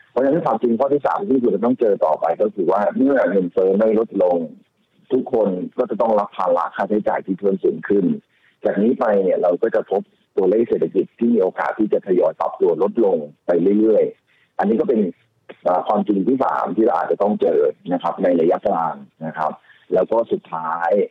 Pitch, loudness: 235 Hz, -19 LUFS